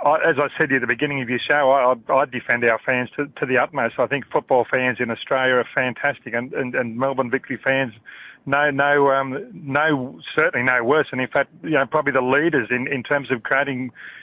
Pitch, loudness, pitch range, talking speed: 135 Hz, -20 LUFS, 125-140 Hz, 225 wpm